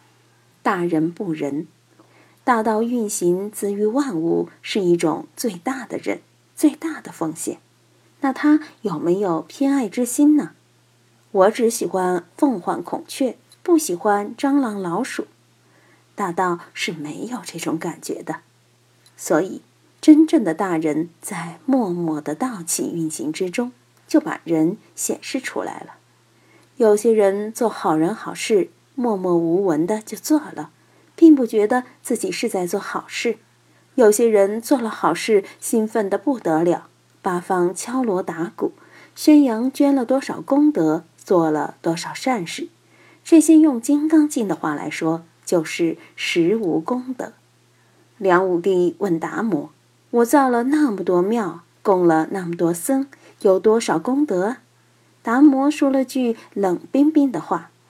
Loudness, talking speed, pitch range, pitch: -20 LUFS, 200 characters per minute, 175-275 Hz, 215 Hz